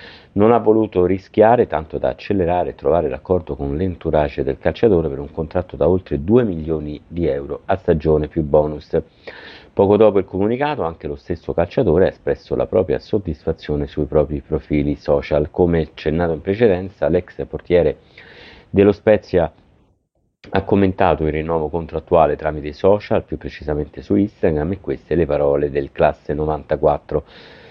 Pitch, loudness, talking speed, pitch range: 80 Hz, -18 LUFS, 155 wpm, 75-95 Hz